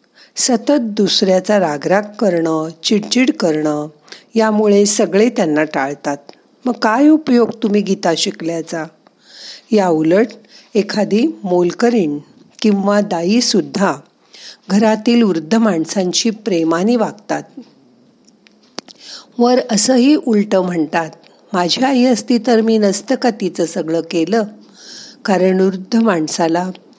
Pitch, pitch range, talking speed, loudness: 205 Hz, 170-225 Hz, 100 wpm, -15 LUFS